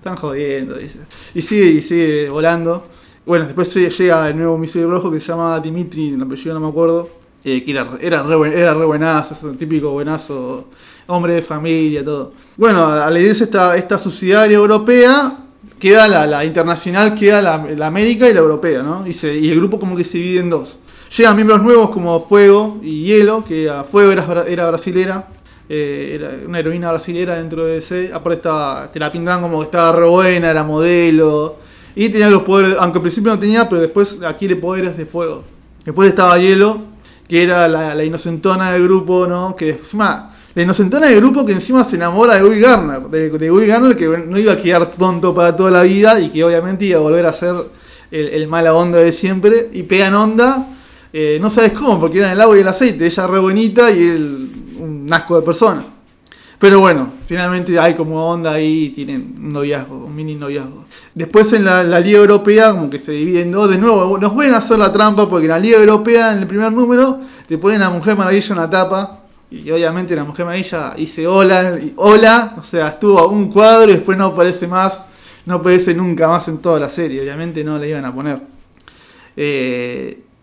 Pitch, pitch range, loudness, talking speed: 175 Hz, 160-205 Hz, -12 LUFS, 205 wpm